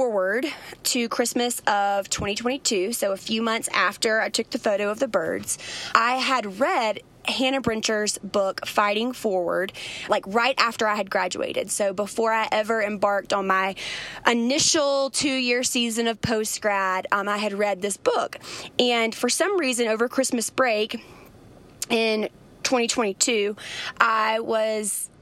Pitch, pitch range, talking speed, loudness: 225 Hz, 205-250 Hz, 145 wpm, -23 LUFS